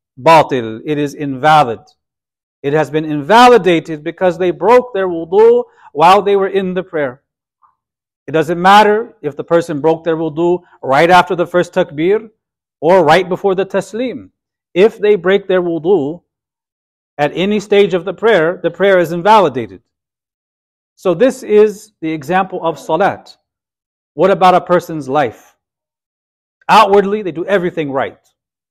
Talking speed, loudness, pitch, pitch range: 145 wpm, -12 LUFS, 175 Hz, 150-200 Hz